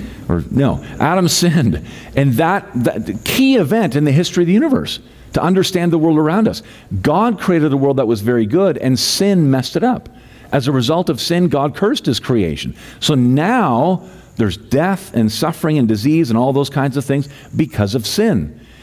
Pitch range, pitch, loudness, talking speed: 125-175 Hz, 145 Hz, -15 LUFS, 195 wpm